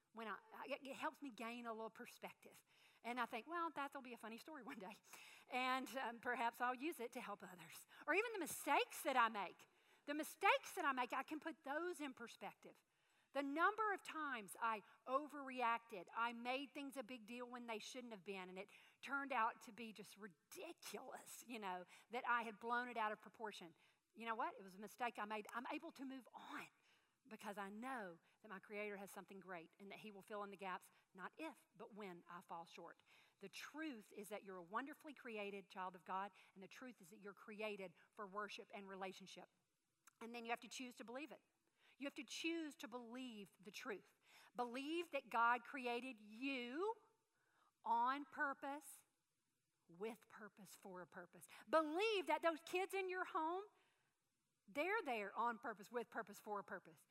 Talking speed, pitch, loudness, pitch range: 195 wpm, 235 Hz, -47 LUFS, 205-280 Hz